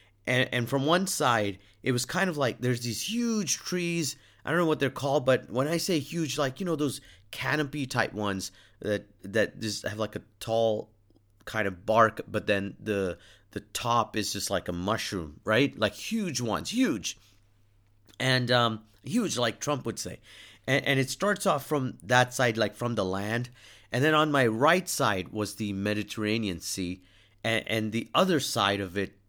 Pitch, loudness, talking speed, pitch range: 115 Hz, -28 LUFS, 185 wpm, 100-140 Hz